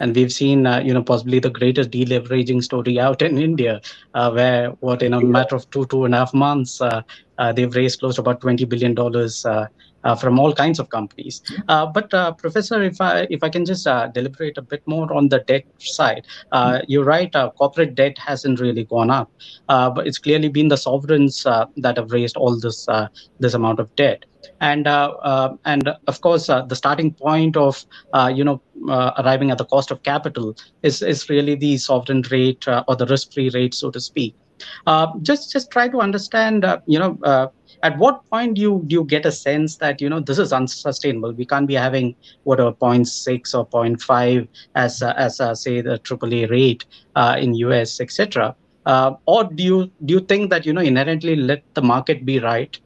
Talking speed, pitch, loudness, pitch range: 215 wpm, 135 Hz, -18 LUFS, 125-150 Hz